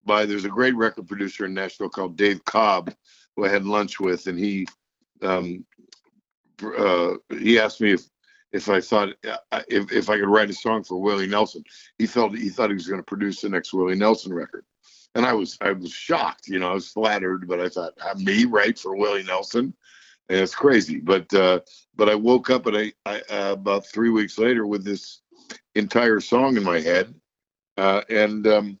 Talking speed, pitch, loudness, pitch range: 205 wpm, 100 Hz, -22 LUFS, 95-105 Hz